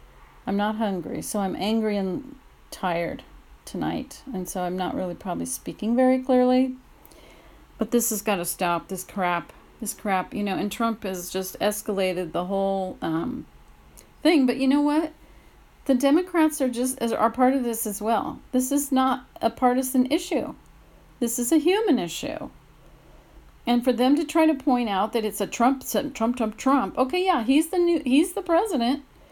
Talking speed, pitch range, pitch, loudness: 180 wpm, 205-275 Hz, 245 Hz, -24 LUFS